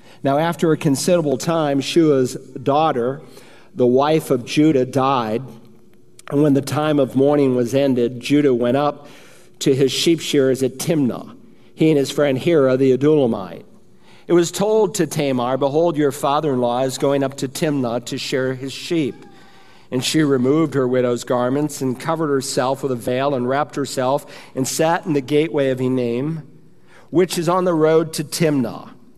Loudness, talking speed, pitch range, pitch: -18 LUFS, 175 wpm, 130-155 Hz, 140 Hz